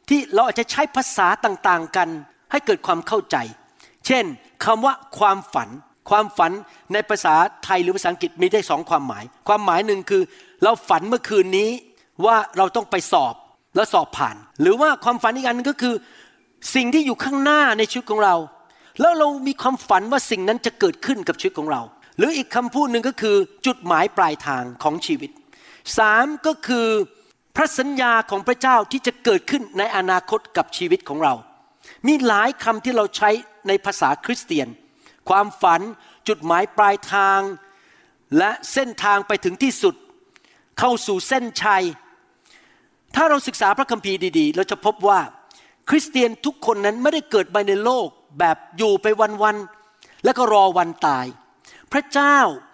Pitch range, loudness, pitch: 200-290 Hz, -19 LUFS, 235 Hz